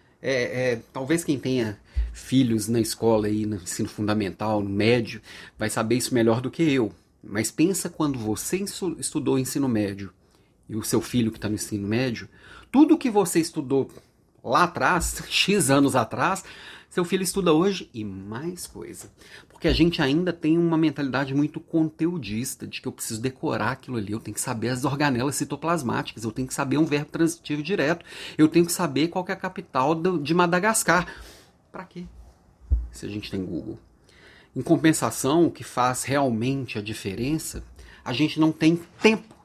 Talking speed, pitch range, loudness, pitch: 175 wpm, 110-165 Hz, -24 LUFS, 135 Hz